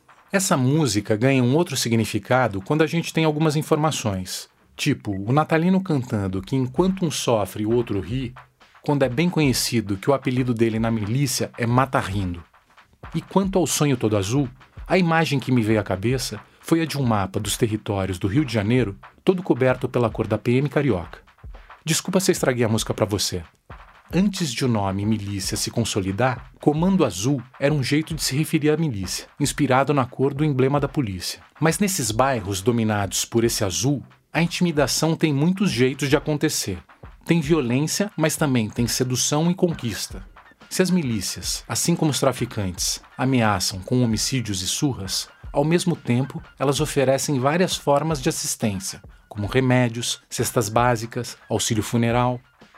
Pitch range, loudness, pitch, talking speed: 110-155 Hz, -22 LUFS, 130 Hz, 165 wpm